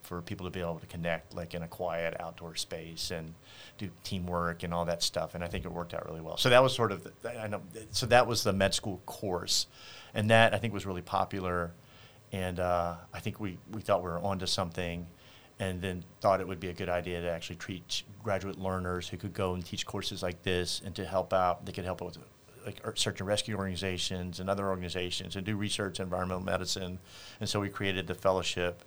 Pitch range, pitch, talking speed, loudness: 90-100 Hz, 95 Hz, 235 wpm, -33 LUFS